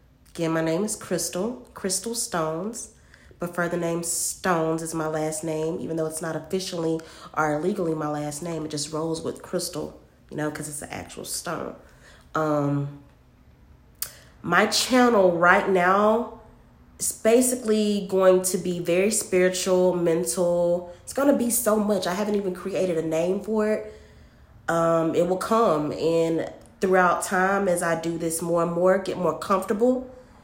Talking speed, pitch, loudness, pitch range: 160 wpm, 175 Hz, -24 LUFS, 160-195 Hz